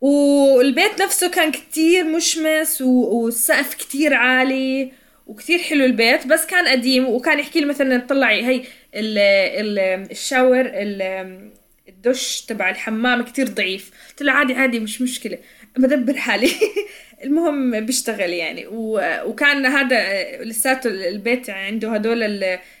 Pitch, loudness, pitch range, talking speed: 255 Hz, -18 LUFS, 220-285 Hz, 125 wpm